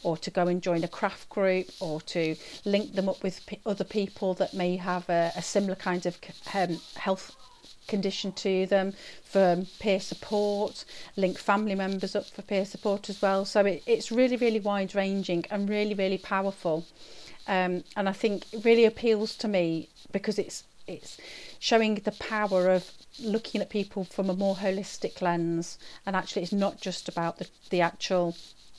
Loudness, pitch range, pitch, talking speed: -29 LUFS, 180-205 Hz, 195 Hz, 180 wpm